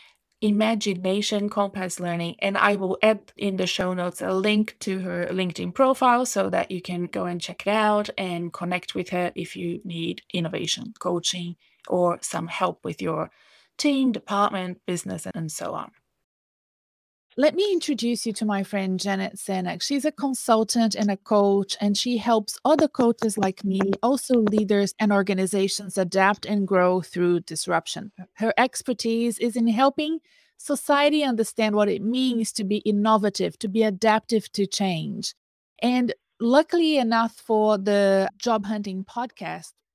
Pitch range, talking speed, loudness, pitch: 190-230 Hz, 155 wpm, -24 LUFS, 205 Hz